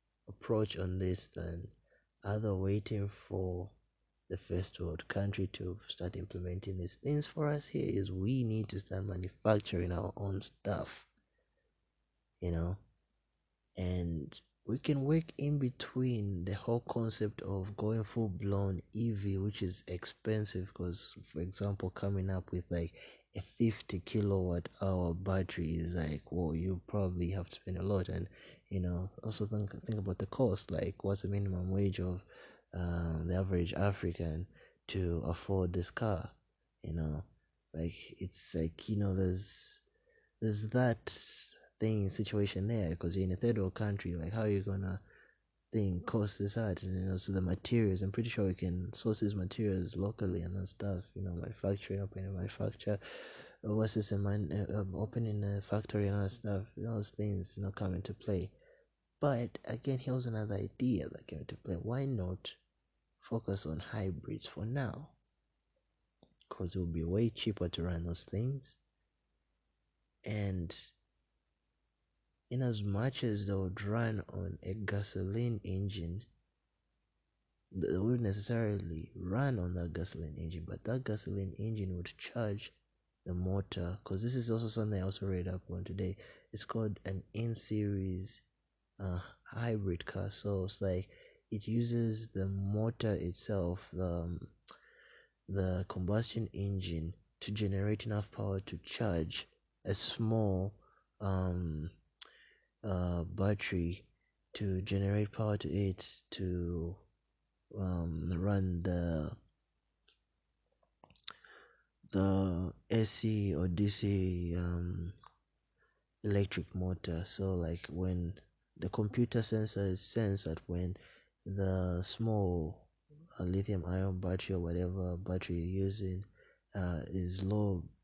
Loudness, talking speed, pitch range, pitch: -37 LUFS, 140 wpm, 90-105 Hz, 95 Hz